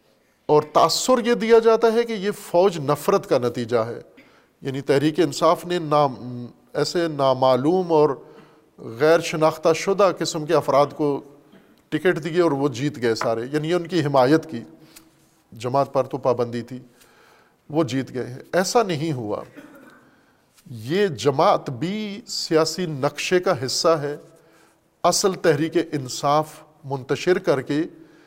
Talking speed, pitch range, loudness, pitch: 140 wpm, 140-180 Hz, -21 LUFS, 155 Hz